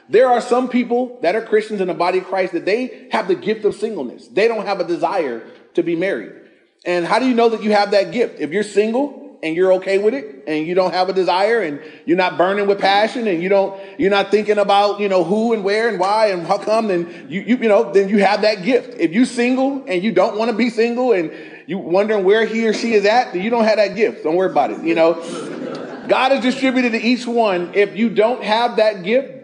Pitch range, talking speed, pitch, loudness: 185-235 Hz, 260 wpm, 210 Hz, -17 LUFS